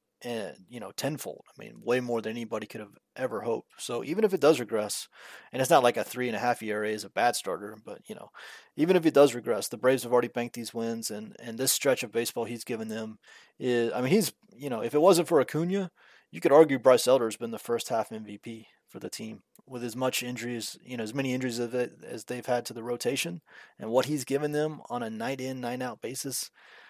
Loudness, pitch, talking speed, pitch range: -28 LUFS, 125 Hz, 250 wpm, 115-135 Hz